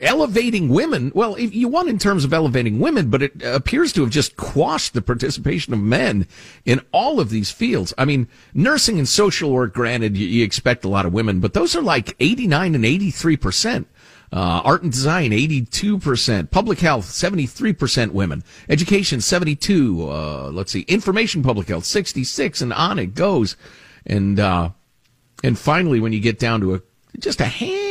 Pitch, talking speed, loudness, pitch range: 130 Hz, 180 wpm, -19 LUFS, 110-175 Hz